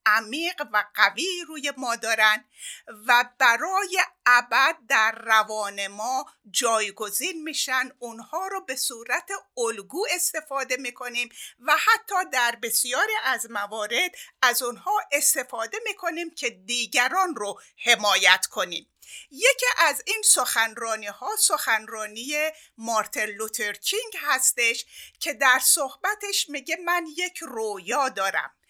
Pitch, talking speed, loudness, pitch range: 255 Hz, 110 wpm, -23 LUFS, 225-335 Hz